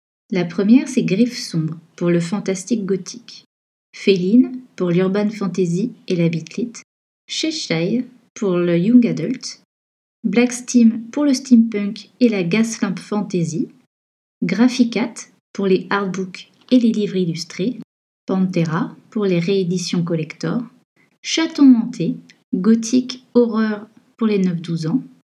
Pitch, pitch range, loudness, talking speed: 215 Hz, 185-240 Hz, -19 LUFS, 120 wpm